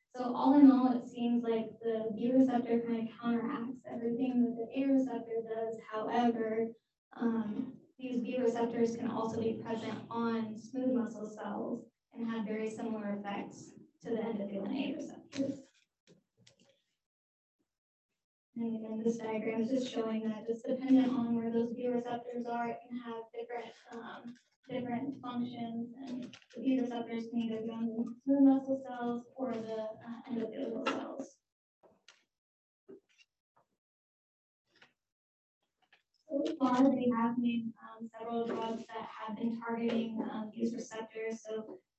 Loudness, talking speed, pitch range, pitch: -35 LUFS, 140 wpm, 225-250 Hz, 235 Hz